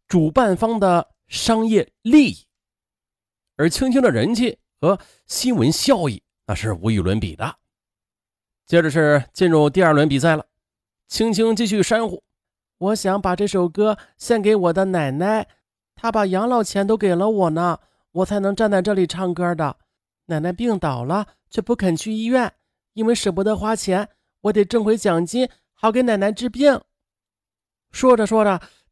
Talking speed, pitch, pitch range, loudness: 225 characters per minute, 195 Hz, 155-220 Hz, -19 LUFS